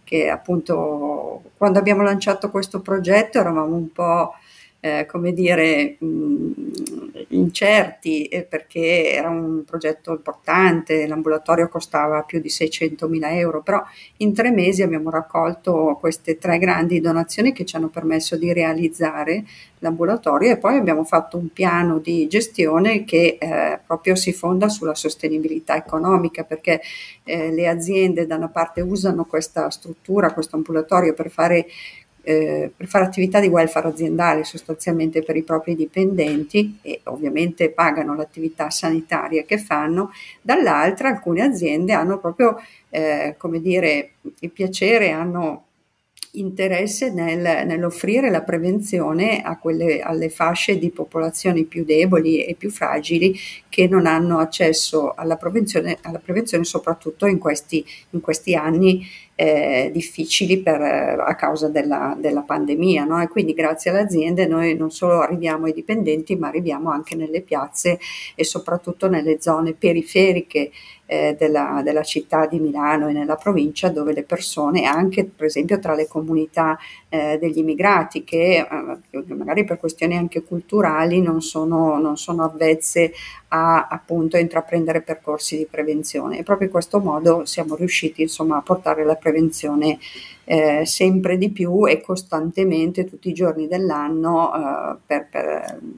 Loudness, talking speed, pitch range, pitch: -19 LUFS, 145 wpm, 160-185 Hz, 165 Hz